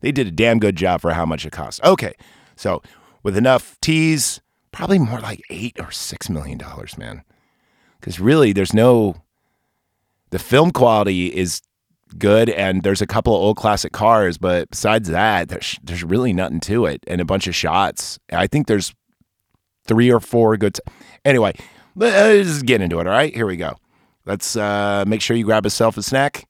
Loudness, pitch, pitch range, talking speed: -17 LUFS, 105 Hz, 90-115 Hz, 190 wpm